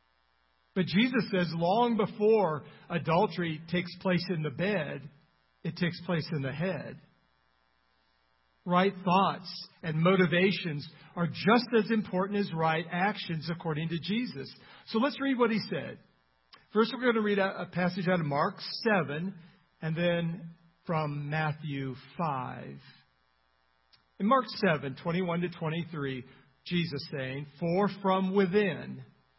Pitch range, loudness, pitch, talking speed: 145-190 Hz, -30 LUFS, 170 Hz, 130 wpm